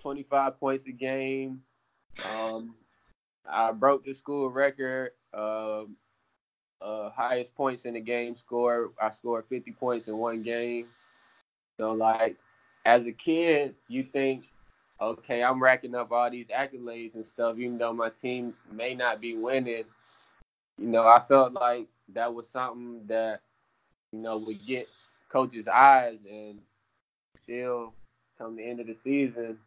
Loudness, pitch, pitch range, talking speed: -28 LUFS, 120 Hz, 115-130 Hz, 145 wpm